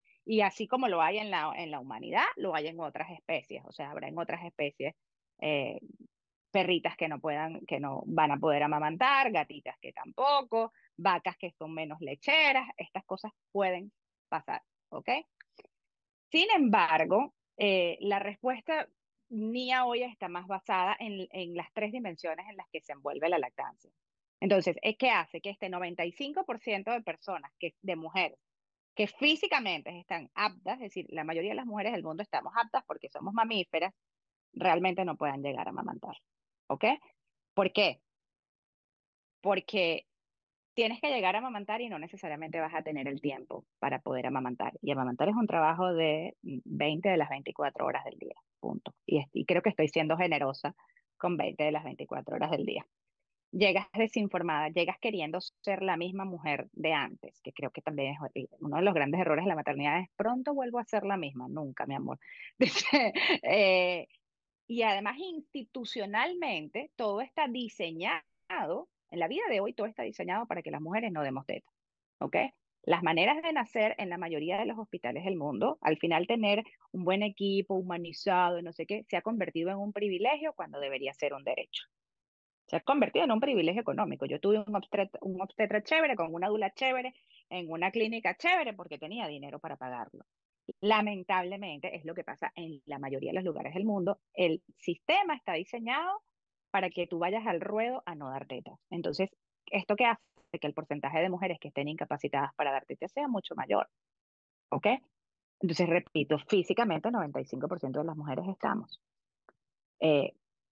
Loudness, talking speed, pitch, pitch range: -32 LUFS, 175 wpm, 185 Hz, 160-220 Hz